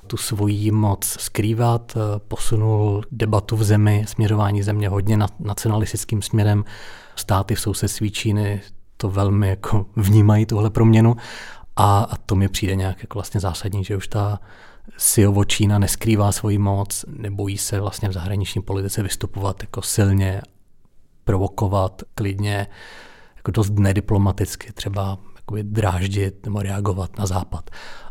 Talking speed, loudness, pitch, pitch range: 125 wpm, -21 LUFS, 105 Hz, 100-110 Hz